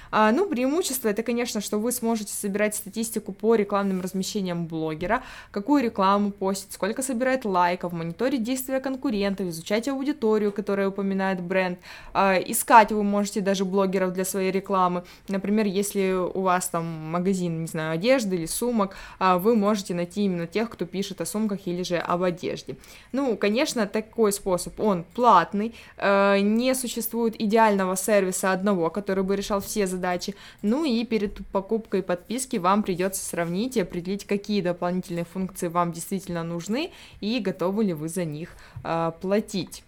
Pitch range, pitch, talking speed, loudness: 185-220 Hz, 200 Hz, 150 wpm, -25 LUFS